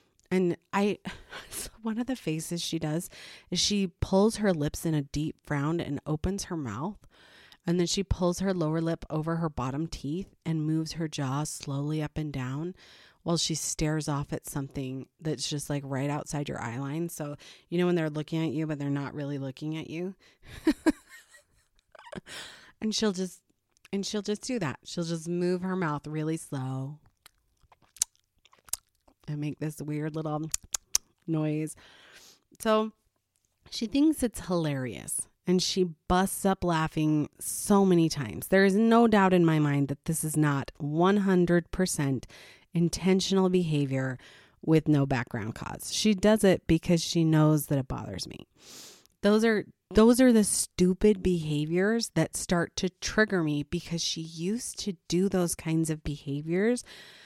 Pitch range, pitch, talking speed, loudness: 150-185 Hz, 165 Hz, 160 wpm, -28 LUFS